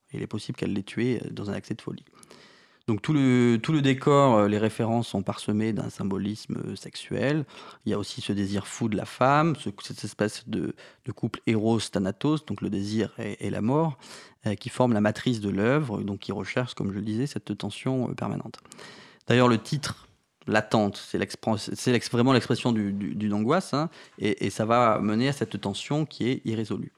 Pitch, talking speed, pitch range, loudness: 110 Hz, 205 wpm, 105-125 Hz, -27 LUFS